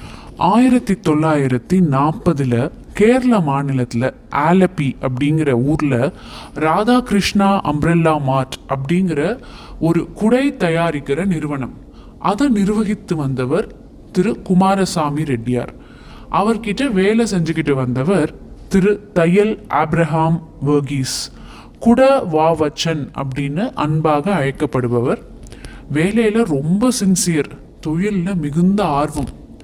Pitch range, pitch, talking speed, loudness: 145-195 Hz, 165 Hz, 85 wpm, -17 LUFS